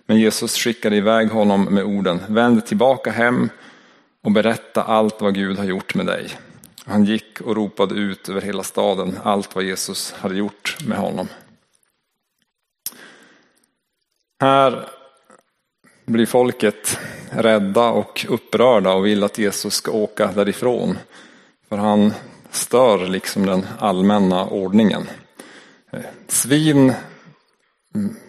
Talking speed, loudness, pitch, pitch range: 115 wpm, -18 LUFS, 105 Hz, 100-115 Hz